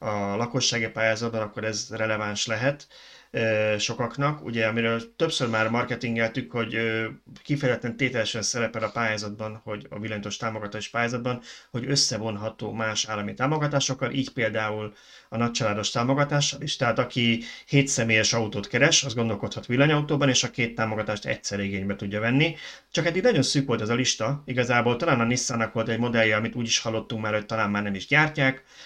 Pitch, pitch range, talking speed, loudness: 115 Hz, 110-130 Hz, 160 wpm, -25 LUFS